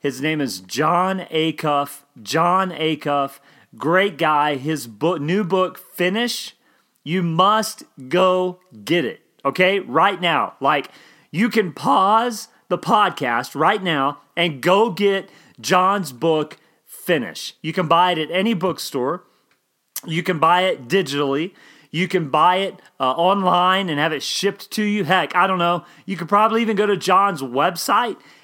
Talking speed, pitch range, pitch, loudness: 150 wpm, 150-190 Hz, 175 Hz, -19 LUFS